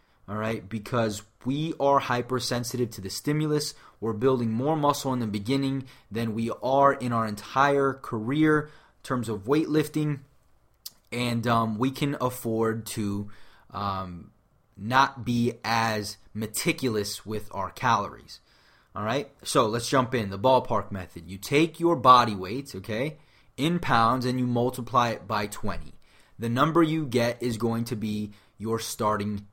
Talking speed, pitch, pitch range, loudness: 150 wpm, 120 Hz, 110-135 Hz, -26 LUFS